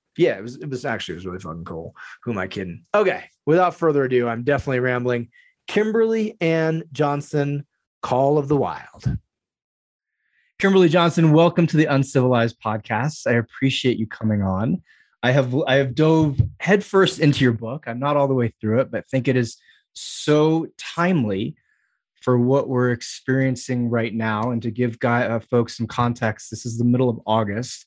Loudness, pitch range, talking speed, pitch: -21 LUFS, 115-155 Hz, 180 wpm, 130 Hz